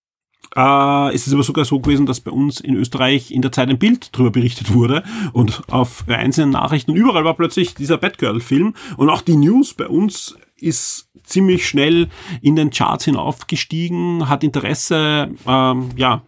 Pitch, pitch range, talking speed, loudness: 140 Hz, 130-165 Hz, 175 wpm, -16 LUFS